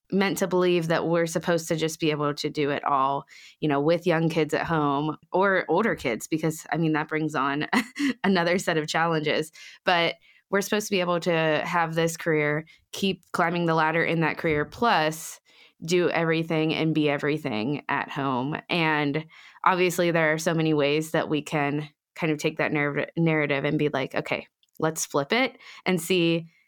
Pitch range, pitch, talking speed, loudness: 150-170 Hz, 160 Hz, 190 wpm, -25 LUFS